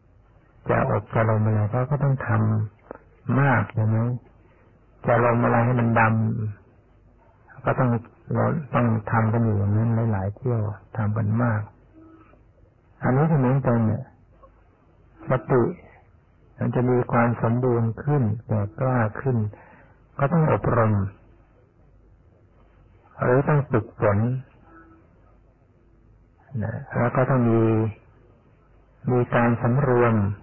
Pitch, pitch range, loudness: 115 Hz, 110-125 Hz, -23 LUFS